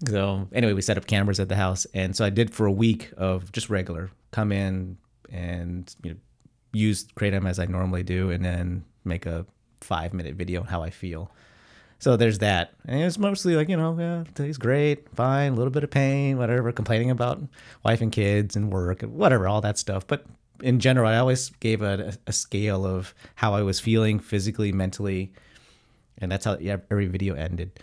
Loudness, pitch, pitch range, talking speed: -25 LUFS, 105 Hz, 95-120 Hz, 205 wpm